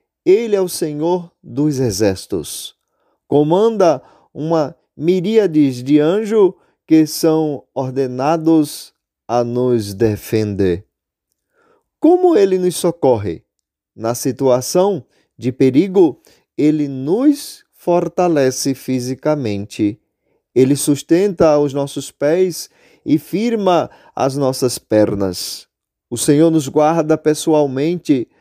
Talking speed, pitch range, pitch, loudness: 95 wpm, 130-180 Hz, 150 Hz, -16 LUFS